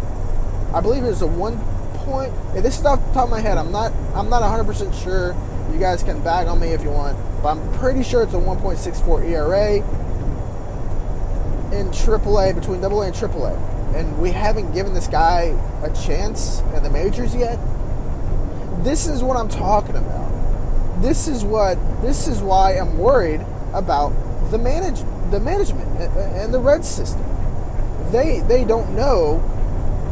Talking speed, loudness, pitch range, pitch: 170 wpm, -21 LUFS, 95-120 Hz, 100 Hz